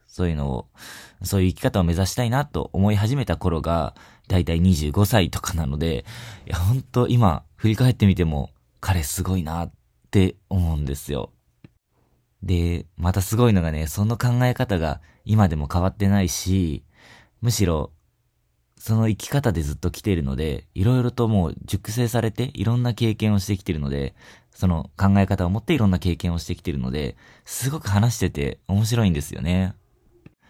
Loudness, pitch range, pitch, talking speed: -23 LUFS, 80-110 Hz, 95 Hz, 340 characters per minute